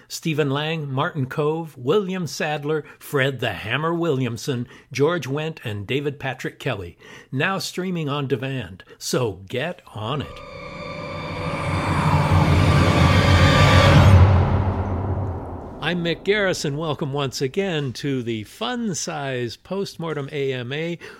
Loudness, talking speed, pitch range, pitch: -22 LUFS, 100 wpm, 125-160 Hz, 145 Hz